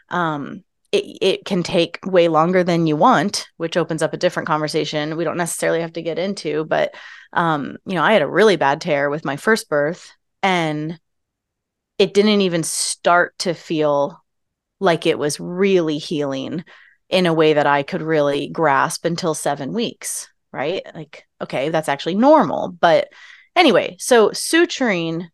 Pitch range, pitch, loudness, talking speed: 150-185 Hz, 165 Hz, -18 LUFS, 165 wpm